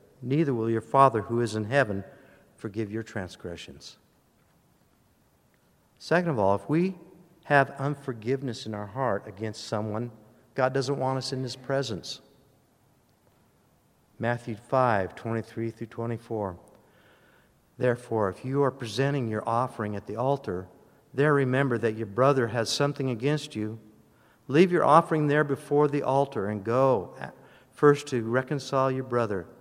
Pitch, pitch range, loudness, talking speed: 125 Hz, 110-140 Hz, -27 LUFS, 140 wpm